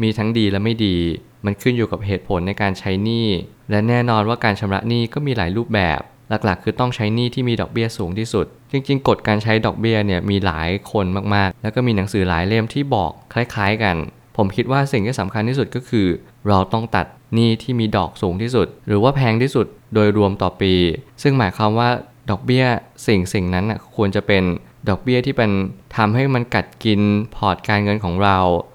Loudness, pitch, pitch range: -19 LUFS, 105 Hz, 100-120 Hz